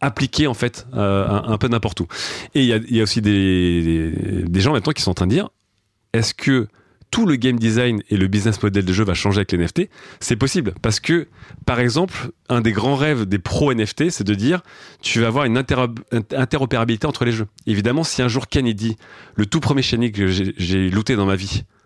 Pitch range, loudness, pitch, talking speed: 100-130 Hz, -19 LUFS, 115 Hz, 230 wpm